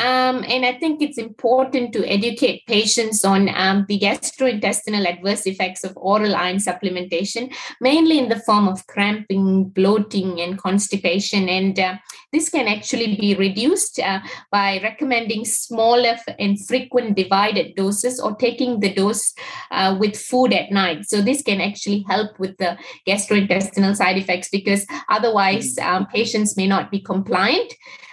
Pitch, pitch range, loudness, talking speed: 205 Hz, 195-240 Hz, -19 LUFS, 150 wpm